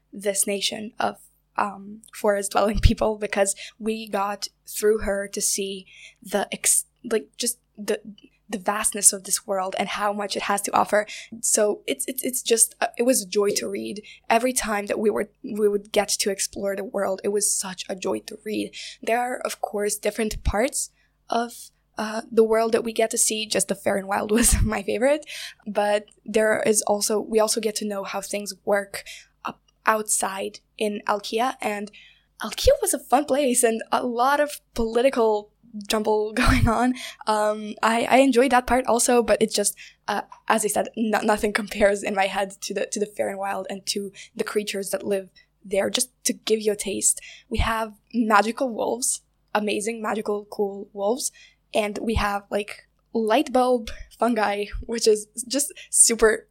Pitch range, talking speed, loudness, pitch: 205-230 Hz, 185 wpm, -23 LUFS, 215 Hz